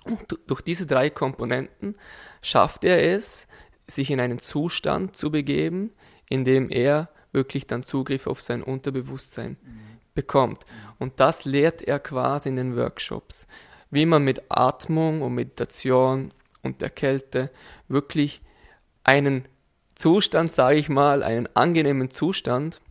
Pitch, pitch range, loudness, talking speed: 135 Hz, 130-150 Hz, -23 LUFS, 130 wpm